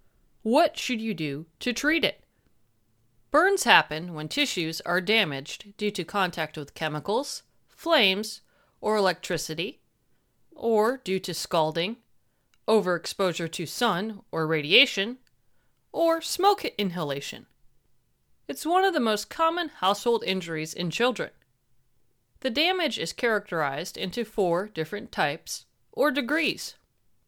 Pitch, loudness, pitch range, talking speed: 205 Hz, -26 LUFS, 165-250 Hz, 115 wpm